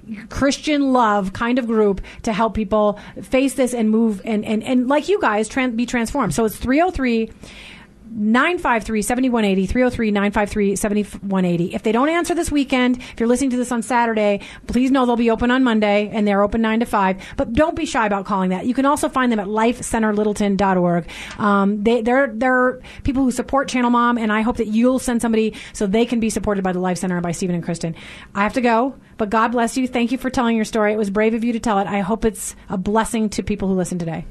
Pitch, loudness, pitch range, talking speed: 225 Hz, -19 LUFS, 210-250 Hz, 225 wpm